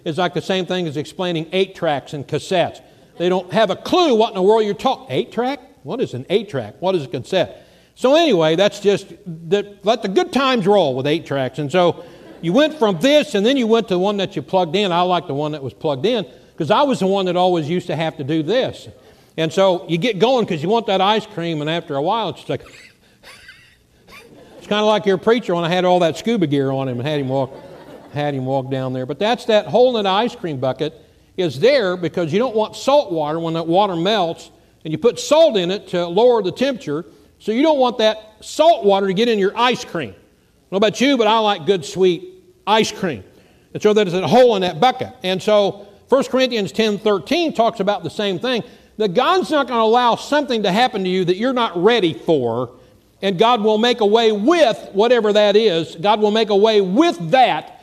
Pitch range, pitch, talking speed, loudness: 165-225 Hz, 195 Hz, 240 wpm, -17 LUFS